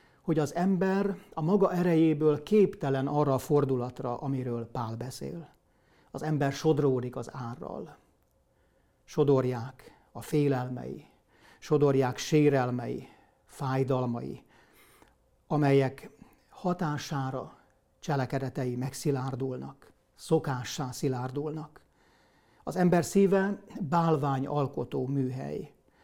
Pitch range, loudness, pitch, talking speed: 130-160 Hz, -29 LUFS, 140 Hz, 85 wpm